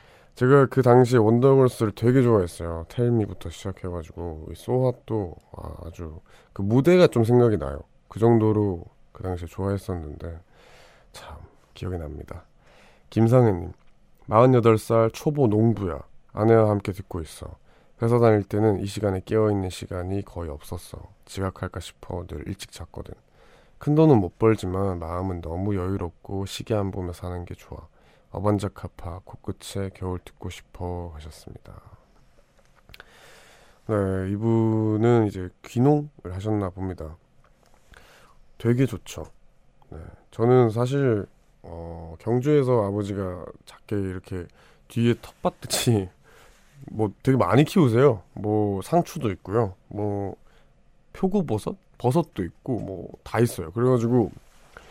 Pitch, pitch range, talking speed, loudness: 100 Hz, 90-115 Hz, 265 characters per minute, -23 LUFS